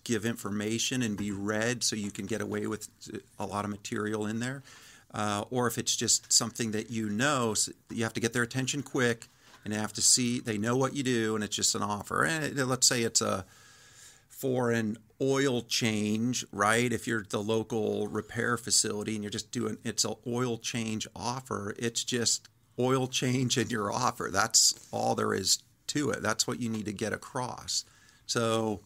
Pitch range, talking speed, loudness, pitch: 105-120 Hz, 200 wpm, -29 LUFS, 115 Hz